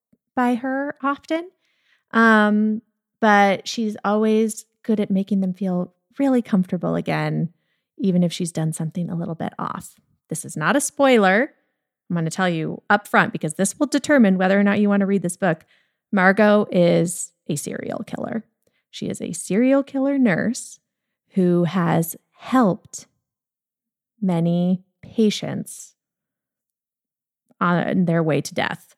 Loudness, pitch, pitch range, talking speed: -21 LUFS, 205 Hz, 180-235 Hz, 145 wpm